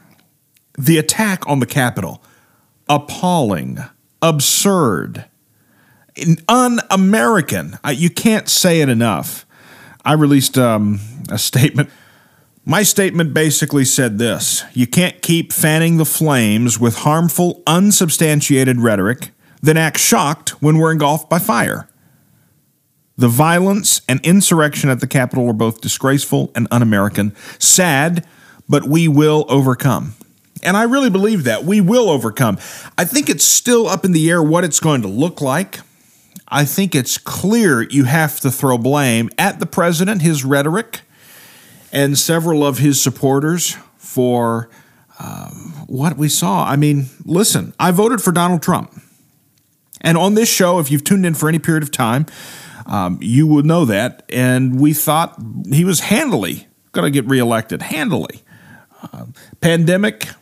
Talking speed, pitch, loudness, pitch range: 145 wpm, 155 Hz, -14 LUFS, 135-175 Hz